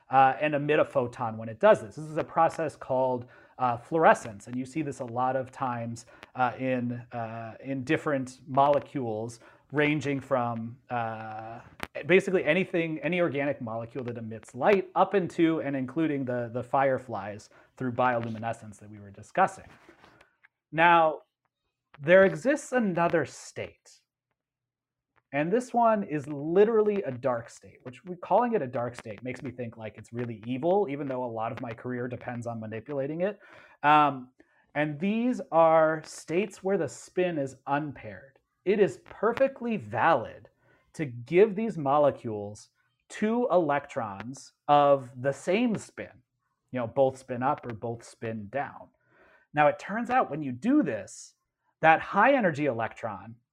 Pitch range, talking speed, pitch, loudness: 120-165 Hz, 155 wpm, 135 Hz, -27 LUFS